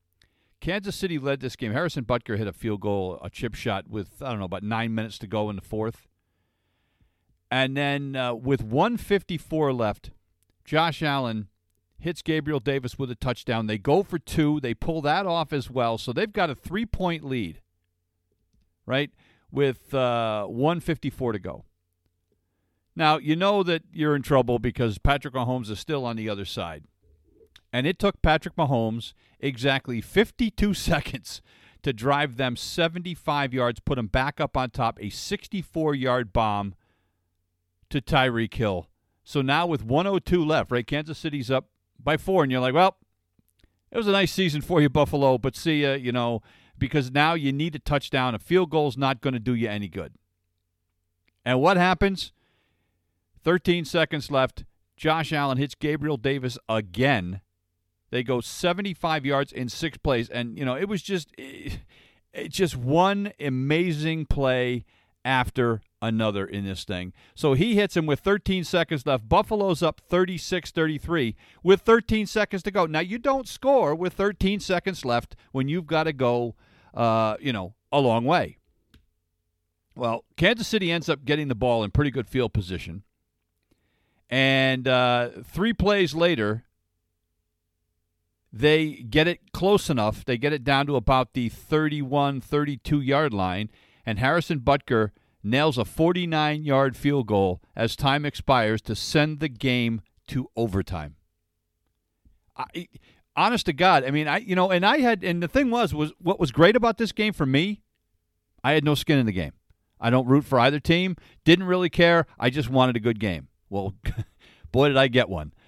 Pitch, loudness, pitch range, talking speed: 130 Hz, -25 LUFS, 105-160 Hz, 170 wpm